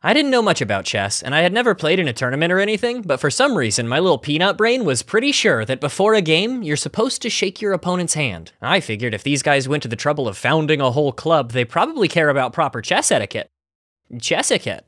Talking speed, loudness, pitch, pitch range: 245 wpm, -18 LUFS, 155 Hz, 130-200 Hz